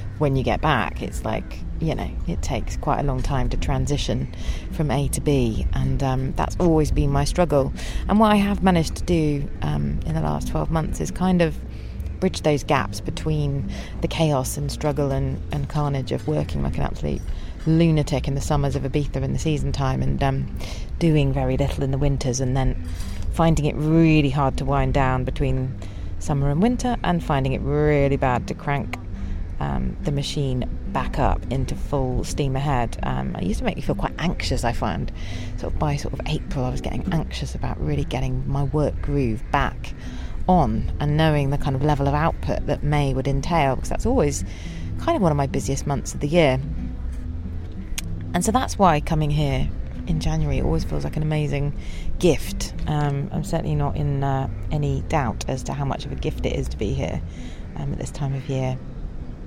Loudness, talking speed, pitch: -23 LUFS, 200 wpm, 135 Hz